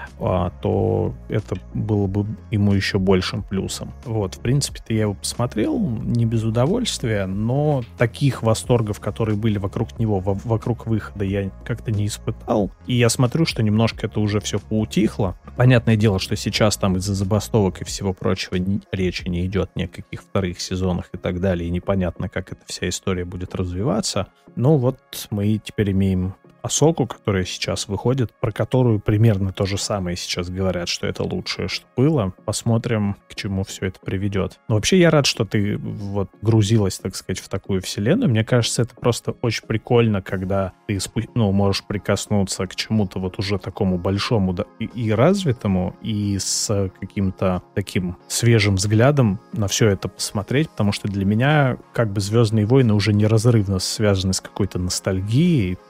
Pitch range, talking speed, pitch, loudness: 95-115 Hz, 165 wpm, 105 Hz, -21 LUFS